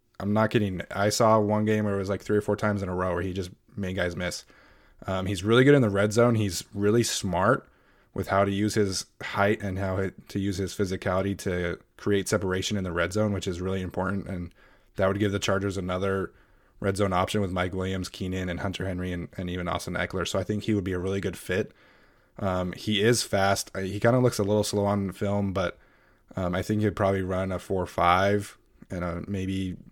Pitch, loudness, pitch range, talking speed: 95 Hz, -27 LUFS, 95-105 Hz, 235 wpm